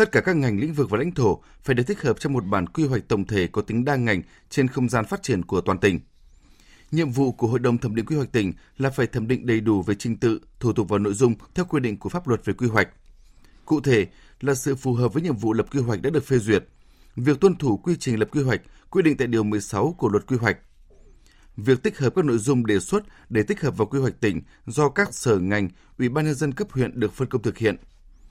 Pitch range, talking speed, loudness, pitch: 105-140 Hz, 270 wpm, -23 LUFS, 120 Hz